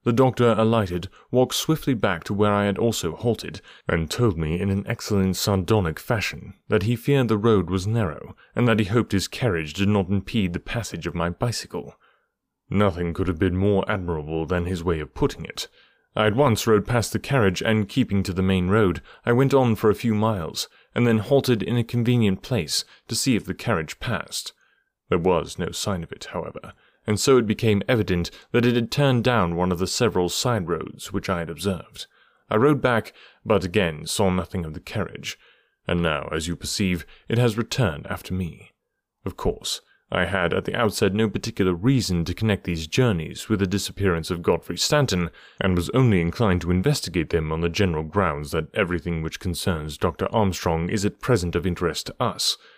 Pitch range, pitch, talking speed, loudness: 90-115 Hz, 100 Hz, 200 wpm, -23 LUFS